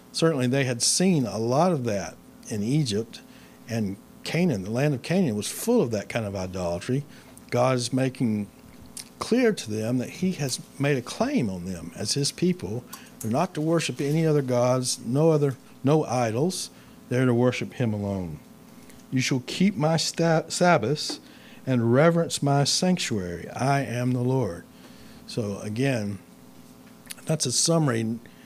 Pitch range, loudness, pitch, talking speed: 115-160 Hz, -25 LUFS, 130 Hz, 160 wpm